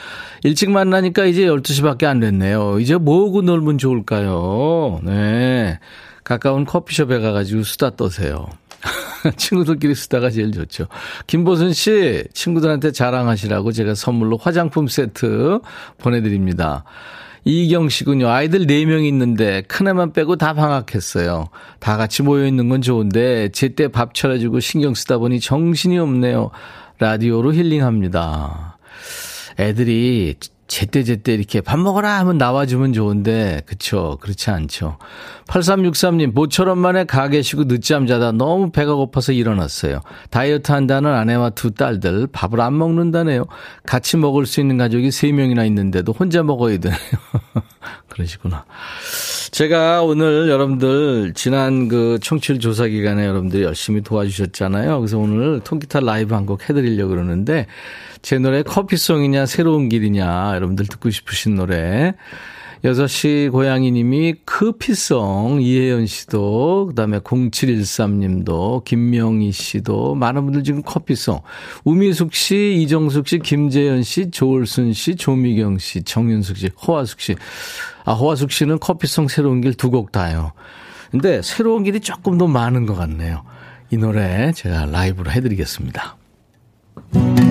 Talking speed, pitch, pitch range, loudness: 310 characters per minute, 125 Hz, 105-155 Hz, -17 LUFS